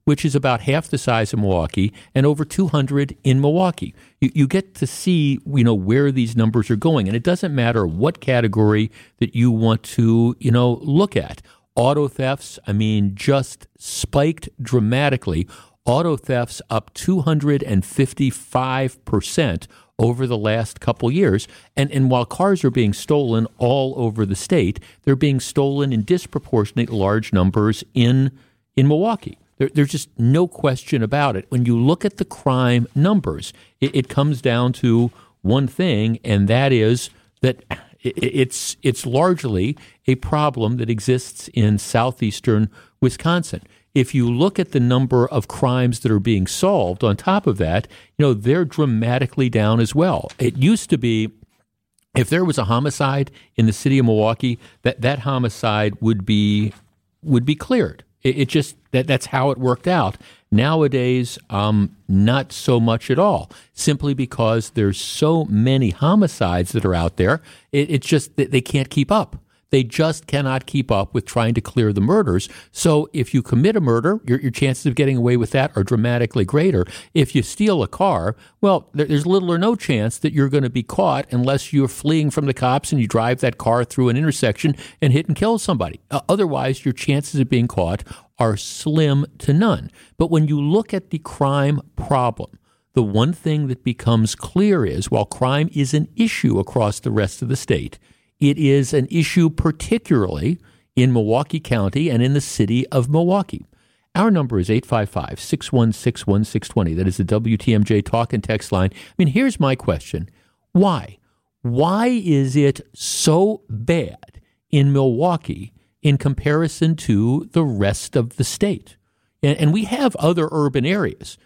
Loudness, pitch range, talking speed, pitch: -19 LUFS, 115-150 Hz, 175 wpm, 130 Hz